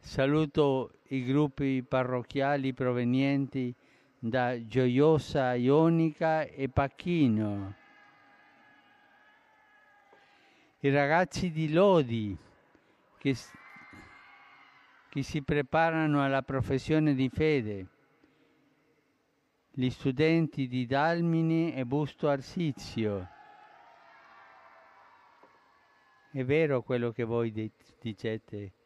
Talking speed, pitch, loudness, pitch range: 75 wpm, 140 Hz, -29 LUFS, 125-160 Hz